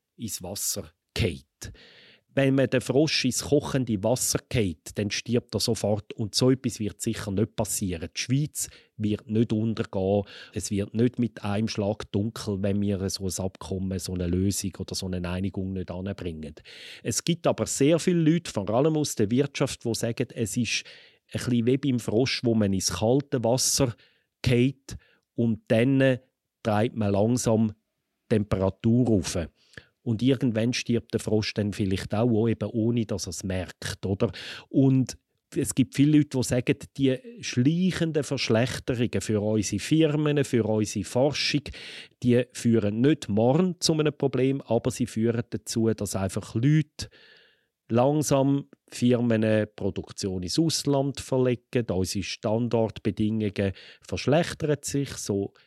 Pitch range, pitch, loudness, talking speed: 100-130 Hz, 115 Hz, -26 LUFS, 150 wpm